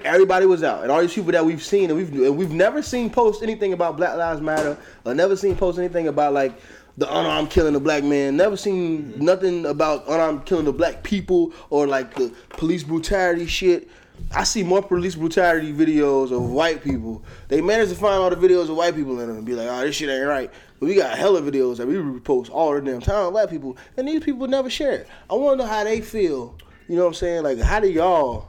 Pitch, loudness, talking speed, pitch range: 170 Hz, -21 LUFS, 240 wpm, 150-200 Hz